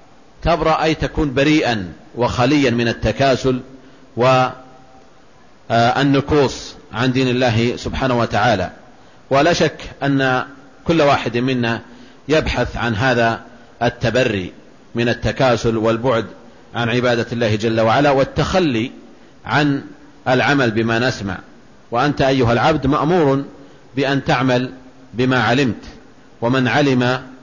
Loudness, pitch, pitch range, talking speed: -17 LUFS, 130 Hz, 120-140 Hz, 100 wpm